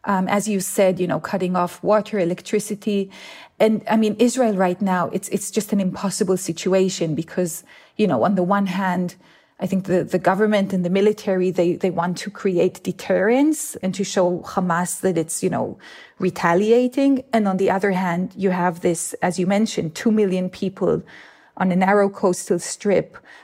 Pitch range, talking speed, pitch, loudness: 180-210 Hz, 180 wpm, 190 Hz, -21 LUFS